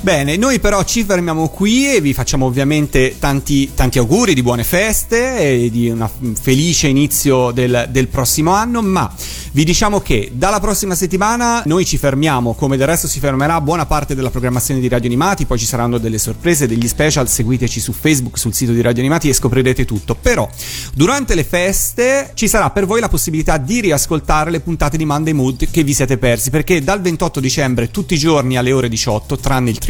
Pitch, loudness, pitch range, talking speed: 140 Hz, -14 LUFS, 125-175 Hz, 200 wpm